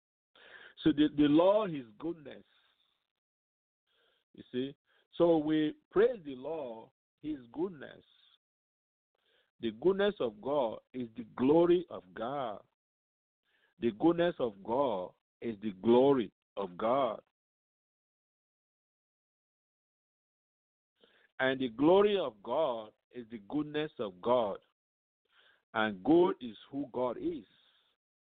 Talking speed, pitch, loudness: 100 wpm, 155 Hz, -32 LUFS